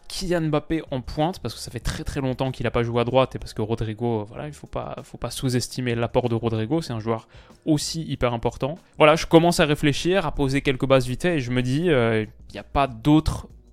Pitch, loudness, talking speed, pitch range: 130 Hz, -23 LUFS, 255 wpm, 120-150 Hz